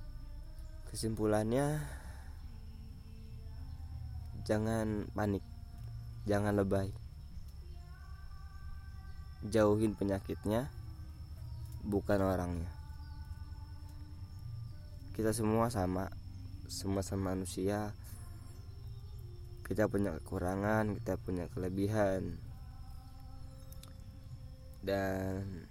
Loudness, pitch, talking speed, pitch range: -36 LUFS, 95 Hz, 50 wpm, 85-105 Hz